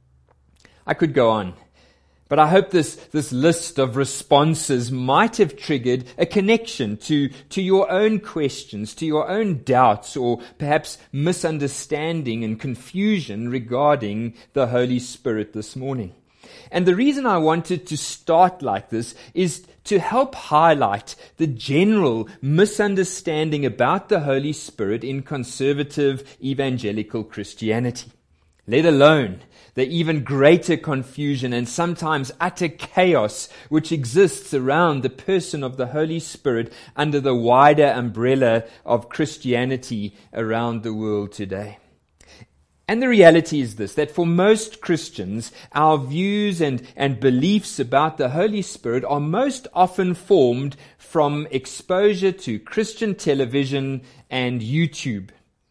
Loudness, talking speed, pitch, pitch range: -20 LUFS, 130 wpm, 140 Hz, 120-170 Hz